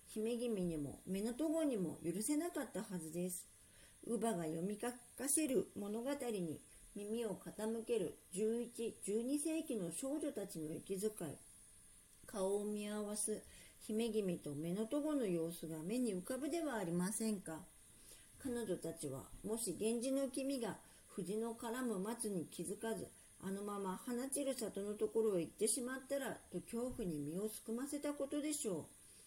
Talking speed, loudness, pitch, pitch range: 285 characters per minute, -42 LUFS, 215 Hz, 175-240 Hz